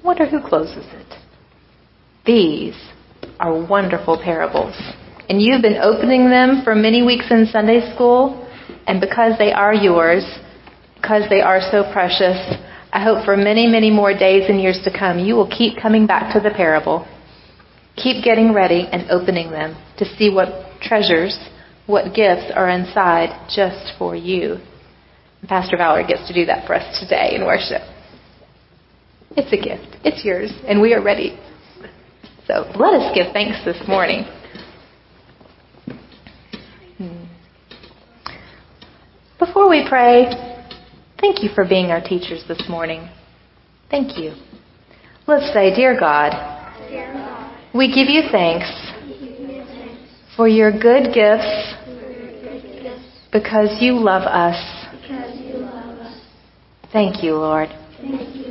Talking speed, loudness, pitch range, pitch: 130 wpm, -16 LUFS, 180-245 Hz, 210 Hz